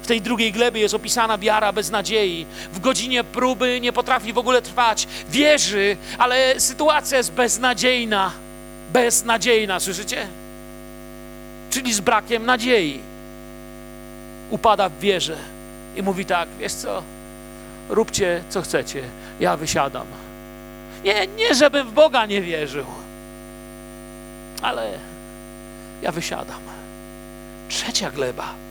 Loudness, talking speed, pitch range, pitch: -20 LUFS, 110 wpm, 200-250 Hz, 230 Hz